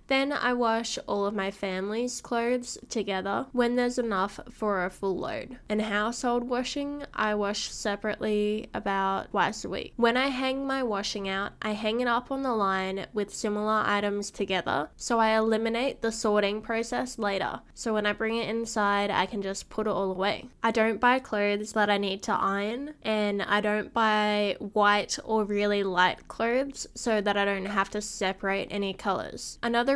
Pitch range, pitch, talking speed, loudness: 200-235 Hz, 215 Hz, 180 wpm, -28 LUFS